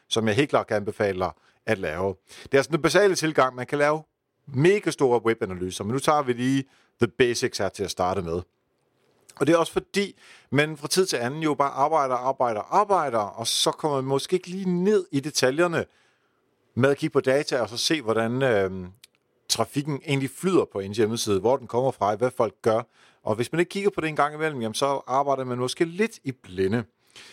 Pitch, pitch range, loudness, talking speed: 140 Hz, 120-160 Hz, -24 LUFS, 215 wpm